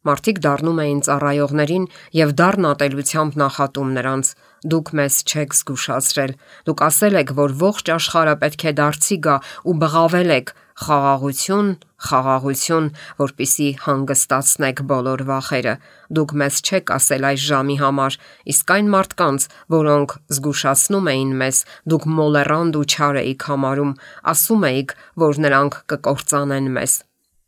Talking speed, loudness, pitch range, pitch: 125 wpm, -17 LUFS, 140-160 Hz, 145 Hz